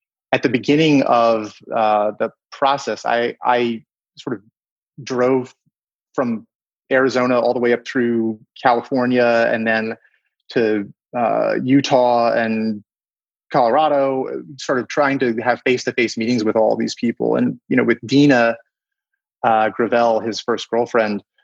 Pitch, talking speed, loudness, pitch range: 120 Hz, 140 wpm, -18 LUFS, 115-130 Hz